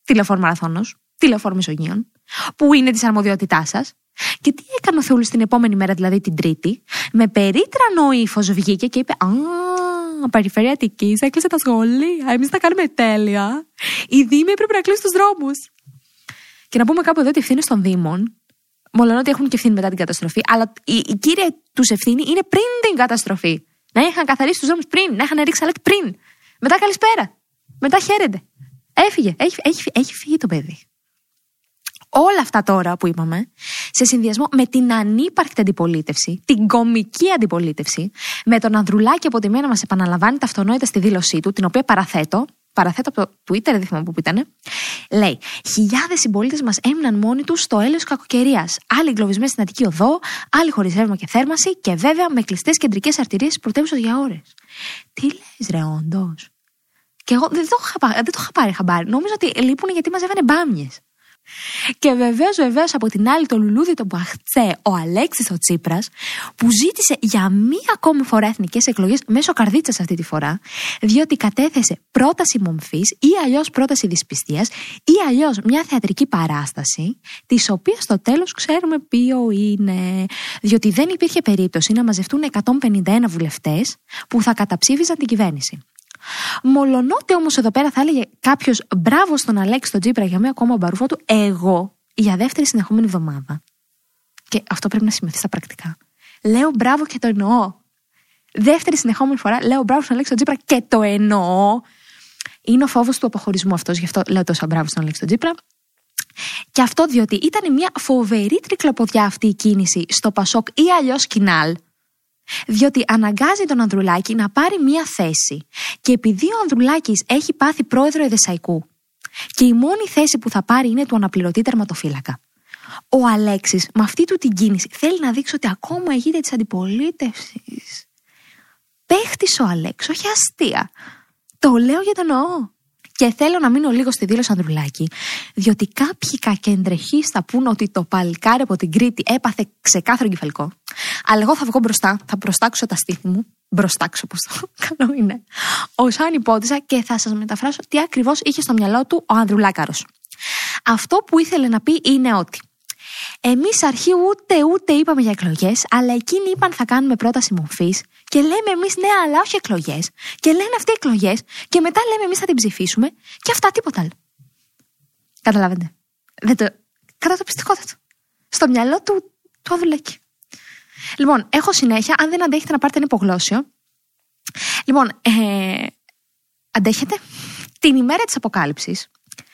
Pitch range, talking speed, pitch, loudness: 200-295 Hz, 165 wpm, 240 Hz, -17 LUFS